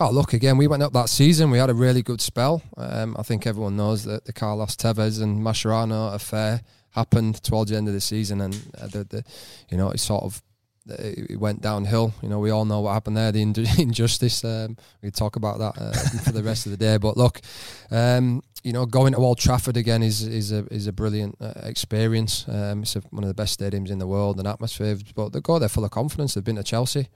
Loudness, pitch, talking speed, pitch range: -23 LUFS, 110 Hz, 245 wpm, 105-120 Hz